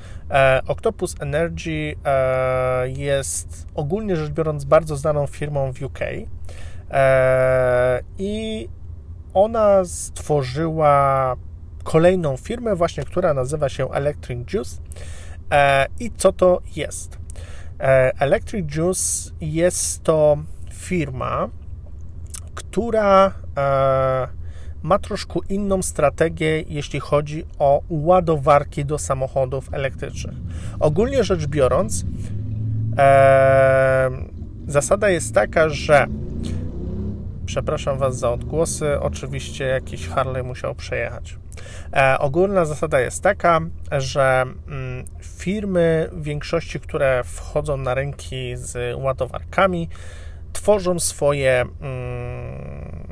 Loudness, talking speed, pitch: -20 LUFS, 95 wpm, 130 Hz